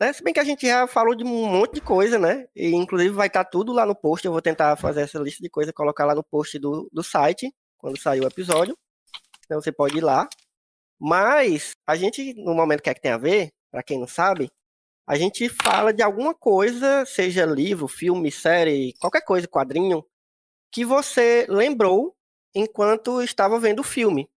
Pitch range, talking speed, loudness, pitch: 150-235 Hz, 200 wpm, -21 LUFS, 185 Hz